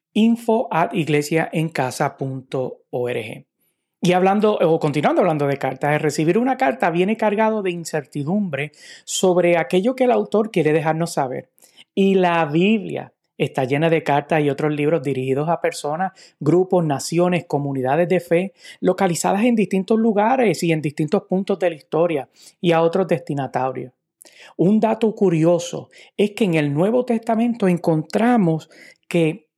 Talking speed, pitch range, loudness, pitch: 140 wpm, 155-200 Hz, -19 LUFS, 170 Hz